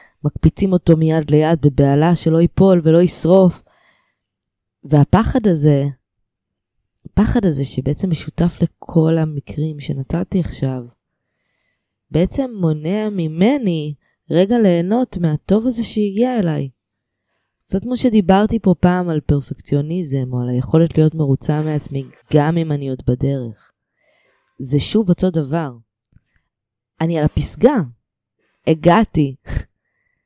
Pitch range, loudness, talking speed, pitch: 135-180 Hz, -17 LUFS, 105 wpm, 160 Hz